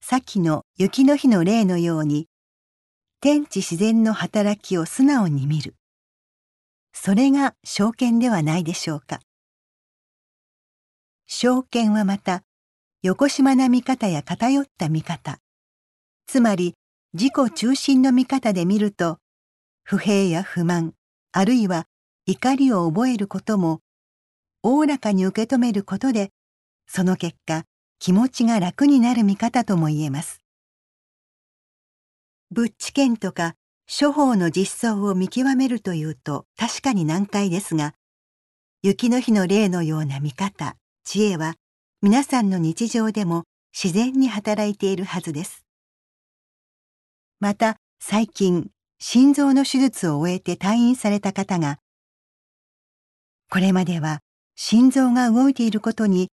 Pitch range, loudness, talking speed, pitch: 170-240 Hz, -21 LUFS, 235 characters per minute, 200 Hz